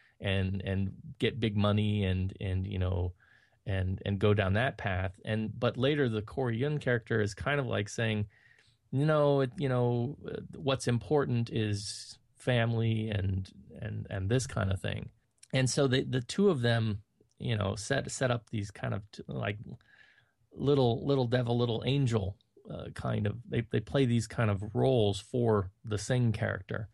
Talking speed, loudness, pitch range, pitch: 175 wpm, -31 LUFS, 105-130 Hz, 115 Hz